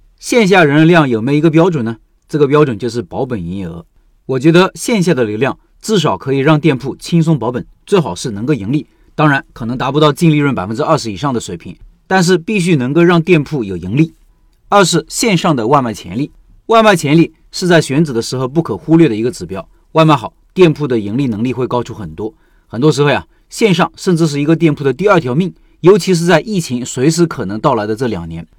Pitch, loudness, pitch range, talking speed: 150 Hz, -13 LUFS, 120-170 Hz, 340 characters per minute